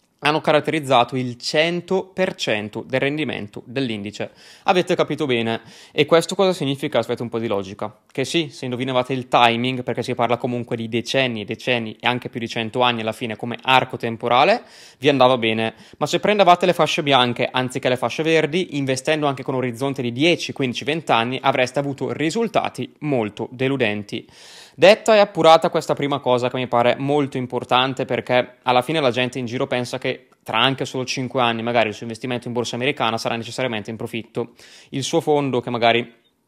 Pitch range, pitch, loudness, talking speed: 120-145 Hz, 125 Hz, -20 LUFS, 185 wpm